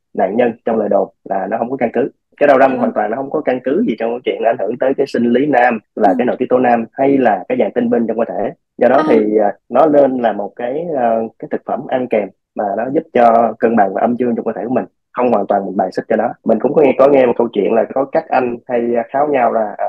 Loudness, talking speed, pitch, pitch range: -15 LUFS, 300 wpm, 120 Hz, 115-135 Hz